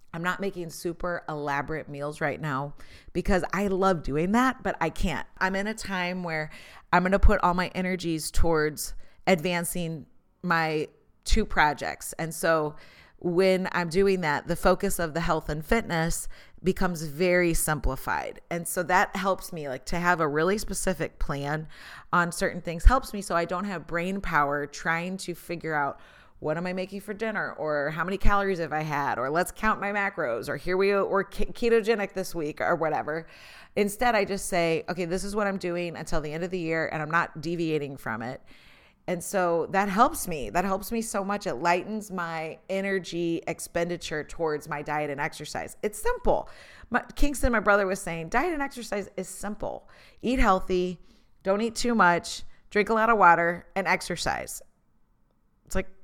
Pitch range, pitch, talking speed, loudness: 160-195 Hz, 175 Hz, 185 wpm, -27 LUFS